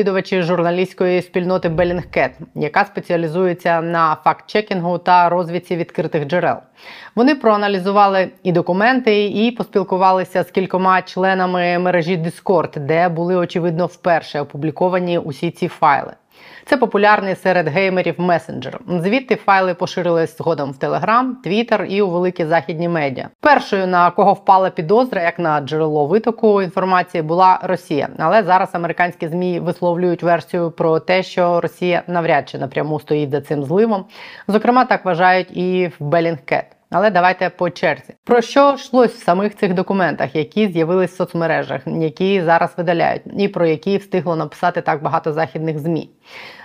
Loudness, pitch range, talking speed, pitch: -17 LUFS, 170-195 Hz, 145 wpm, 180 Hz